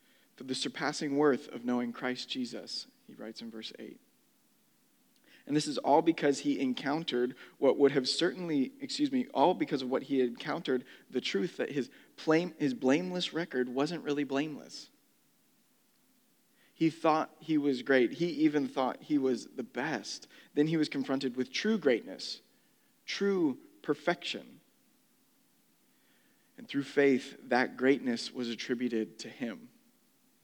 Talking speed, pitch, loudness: 145 wpm, 160 Hz, -32 LUFS